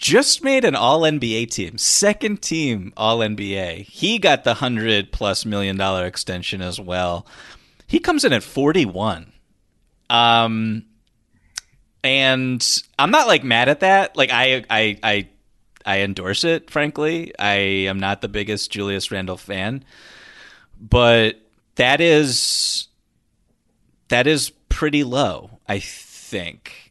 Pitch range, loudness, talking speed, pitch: 100-145 Hz, -18 LUFS, 125 wpm, 115 Hz